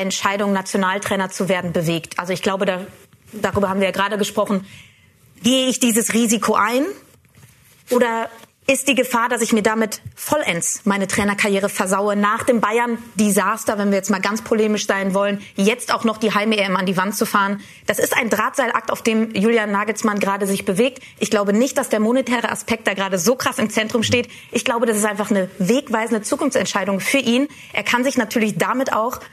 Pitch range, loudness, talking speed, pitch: 200-235 Hz, -19 LUFS, 190 wpm, 215 Hz